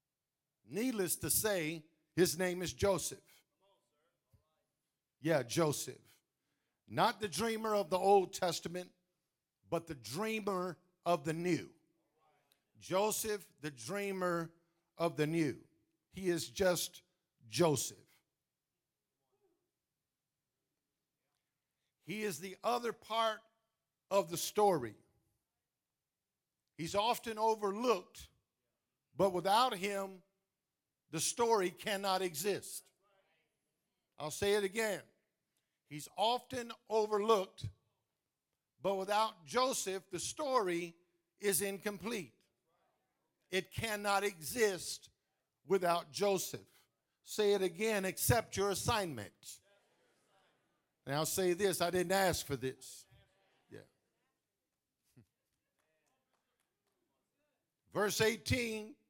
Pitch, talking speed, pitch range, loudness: 180 Hz, 85 wpm, 150-205 Hz, -36 LUFS